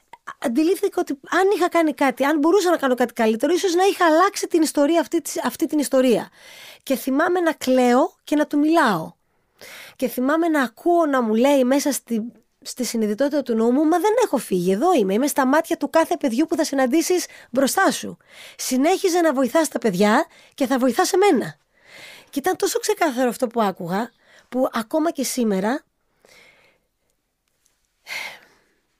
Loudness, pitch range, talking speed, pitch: -20 LUFS, 255-335 Hz, 165 wpm, 290 Hz